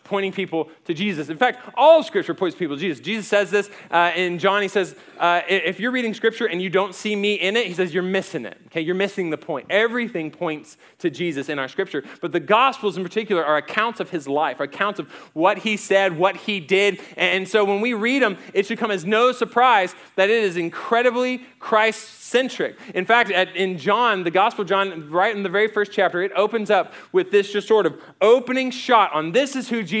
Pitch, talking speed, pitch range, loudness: 200 Hz, 230 wpm, 180-225 Hz, -21 LUFS